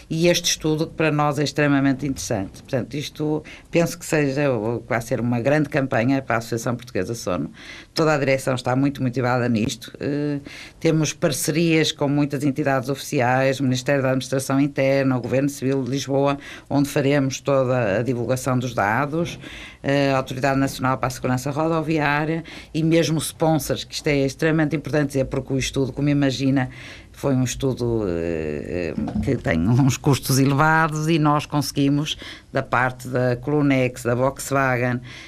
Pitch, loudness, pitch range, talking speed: 135 Hz, -22 LUFS, 130-150 Hz, 165 wpm